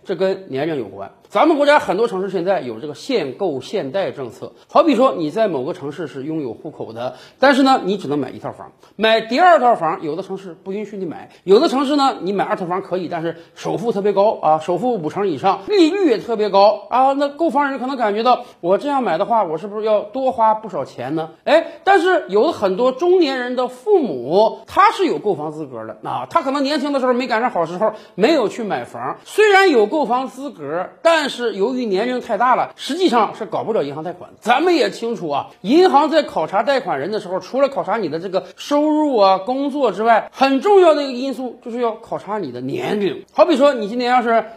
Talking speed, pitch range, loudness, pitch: 335 characters per minute, 195-290 Hz, -17 LUFS, 240 Hz